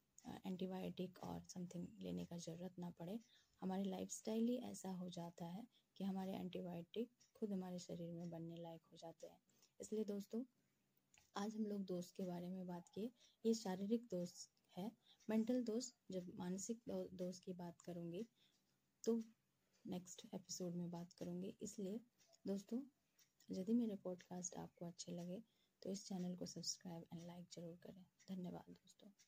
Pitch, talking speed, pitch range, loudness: 185 Hz, 160 wpm, 175-215 Hz, -49 LUFS